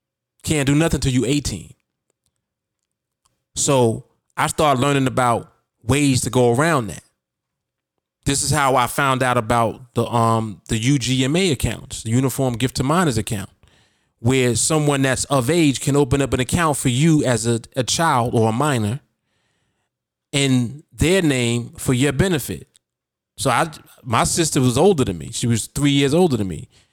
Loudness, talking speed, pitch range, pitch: -19 LUFS, 165 wpm, 115-145 Hz, 130 Hz